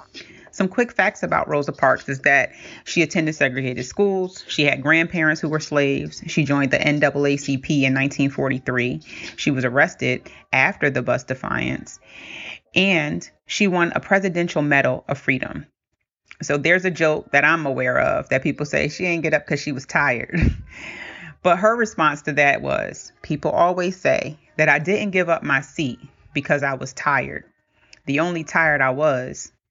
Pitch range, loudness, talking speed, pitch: 140-175 Hz, -20 LUFS, 170 wpm, 150 Hz